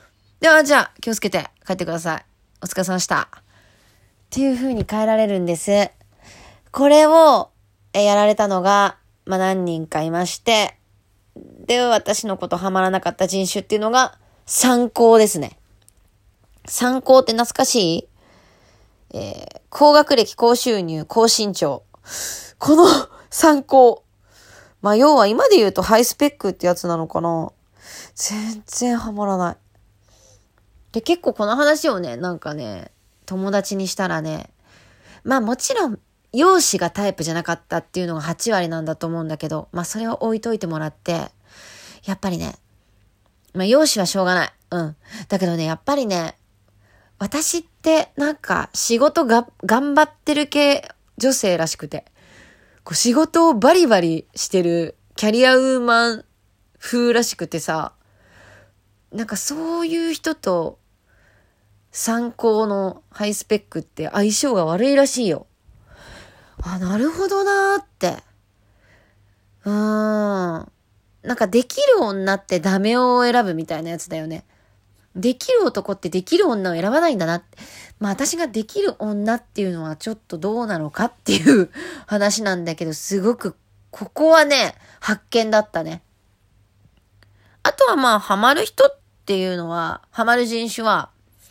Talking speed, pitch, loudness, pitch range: 275 characters per minute, 195 Hz, -18 LUFS, 160-240 Hz